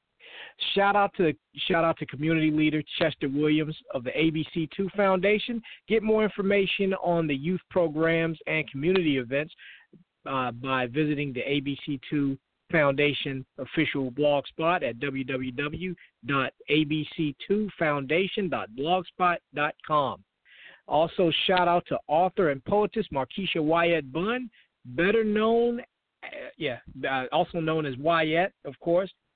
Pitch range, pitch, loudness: 145-190 Hz, 165 Hz, -27 LUFS